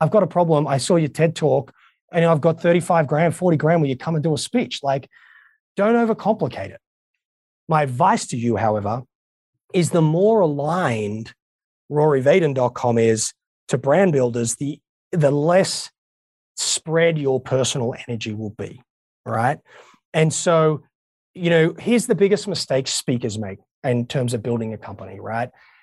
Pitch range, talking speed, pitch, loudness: 120-170 Hz, 160 wpm, 145 Hz, -20 LUFS